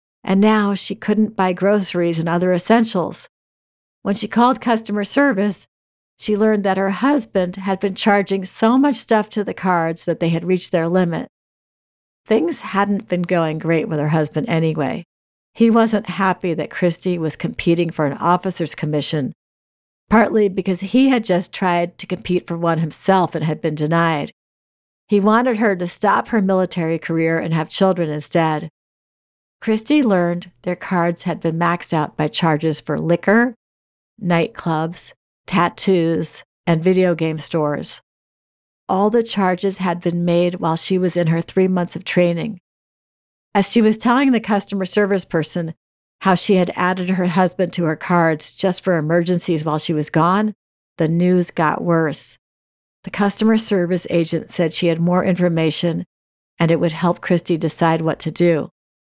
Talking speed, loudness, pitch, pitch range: 165 wpm, -18 LUFS, 180 Hz, 165-200 Hz